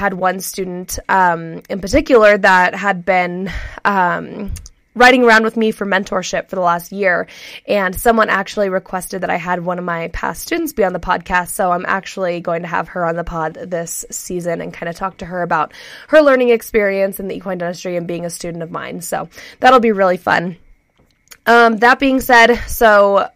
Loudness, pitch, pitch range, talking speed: -15 LUFS, 190 Hz, 175-220 Hz, 200 wpm